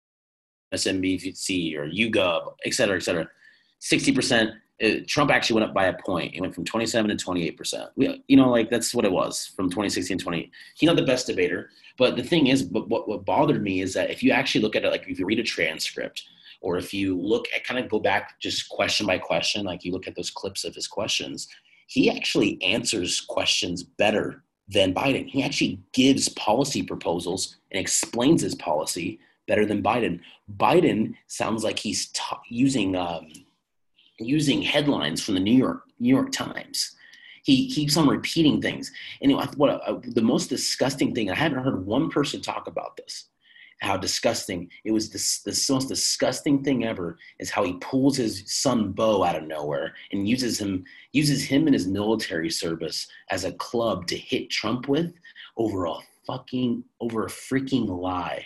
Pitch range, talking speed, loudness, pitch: 95-145 Hz, 185 wpm, -24 LUFS, 120 Hz